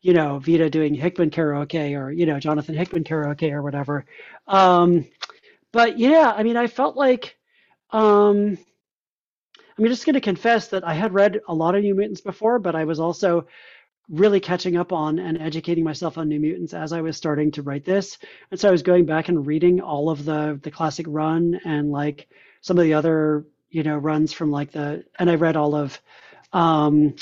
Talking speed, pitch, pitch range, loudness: 200 wpm, 165 Hz, 155-195 Hz, -21 LUFS